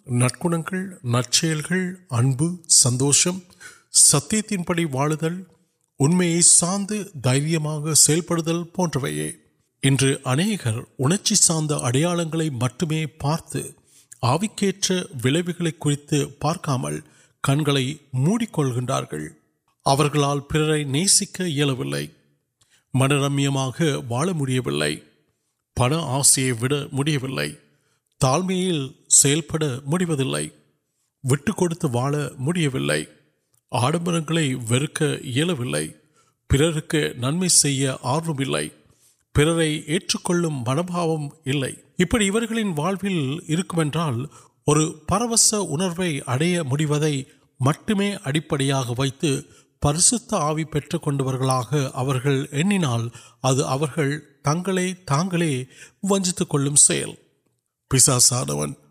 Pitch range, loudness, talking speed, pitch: 135-170 Hz, -21 LUFS, 45 wpm, 150 Hz